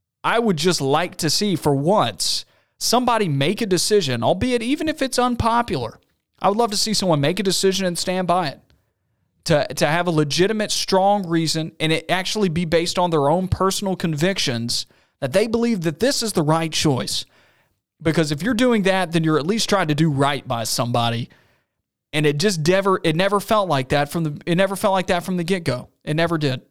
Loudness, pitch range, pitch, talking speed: -20 LUFS, 155-200 Hz, 180 Hz, 210 wpm